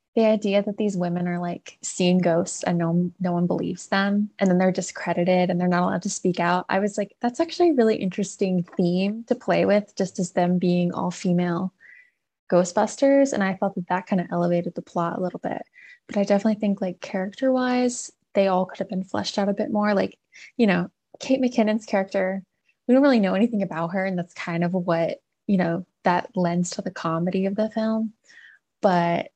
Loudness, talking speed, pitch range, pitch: -23 LUFS, 215 wpm, 180-215 Hz, 195 Hz